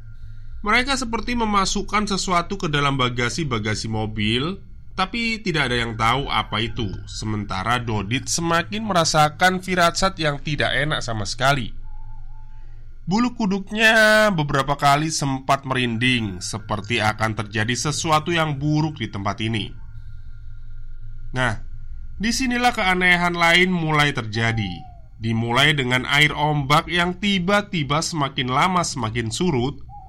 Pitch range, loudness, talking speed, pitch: 110-175 Hz, -20 LUFS, 110 wpm, 135 Hz